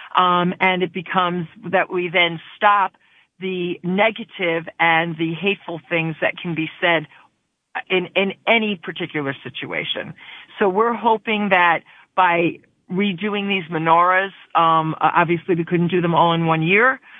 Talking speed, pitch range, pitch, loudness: 145 wpm, 165-190 Hz, 180 Hz, -19 LUFS